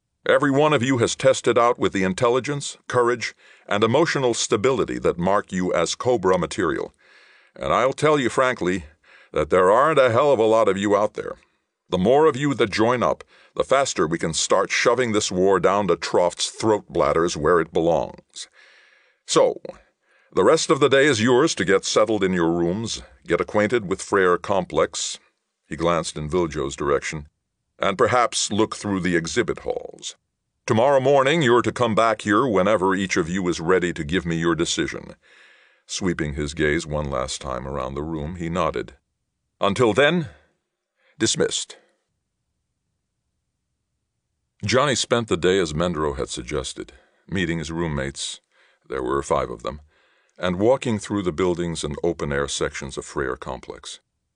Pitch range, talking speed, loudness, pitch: 80-130 Hz, 165 wpm, -21 LUFS, 95 Hz